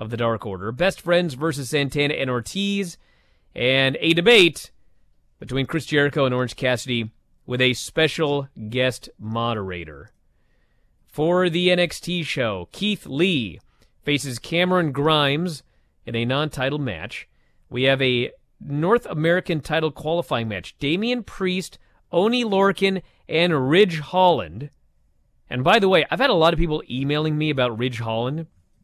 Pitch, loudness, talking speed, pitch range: 145 Hz, -21 LUFS, 140 wpm, 120-170 Hz